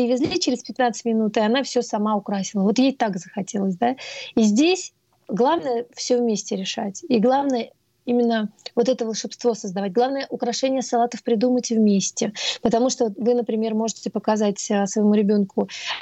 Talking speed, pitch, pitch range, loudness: 150 wpm, 235 Hz, 215-245 Hz, -22 LUFS